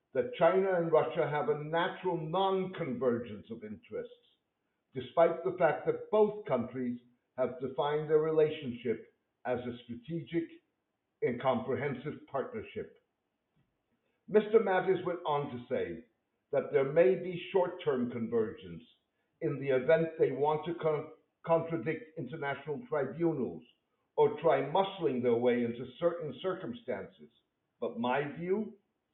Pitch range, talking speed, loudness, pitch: 140-190 Hz, 120 wpm, -32 LUFS, 165 Hz